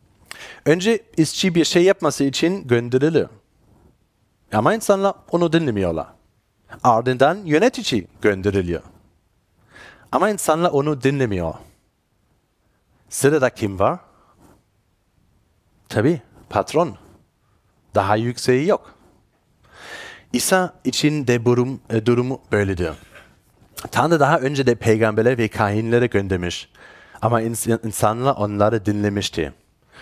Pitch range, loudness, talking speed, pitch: 100-145 Hz, -19 LUFS, 90 wpm, 115 Hz